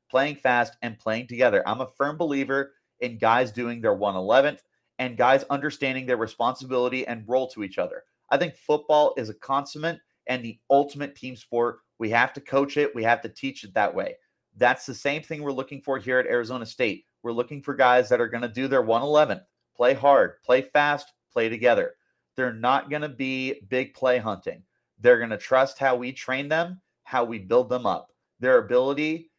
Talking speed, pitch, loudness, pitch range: 195 wpm, 135 Hz, -24 LUFS, 125-145 Hz